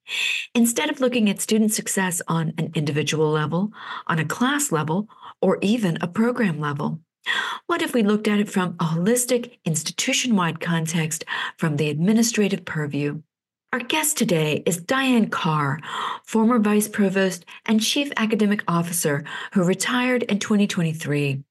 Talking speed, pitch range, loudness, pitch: 145 wpm, 160-230 Hz, -22 LUFS, 195 Hz